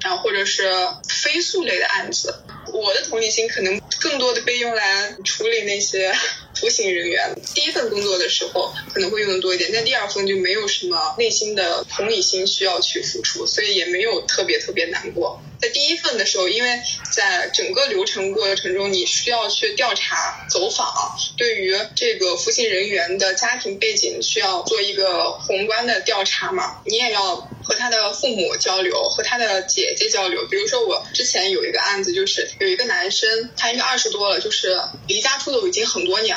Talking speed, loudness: 300 characters per minute, -19 LUFS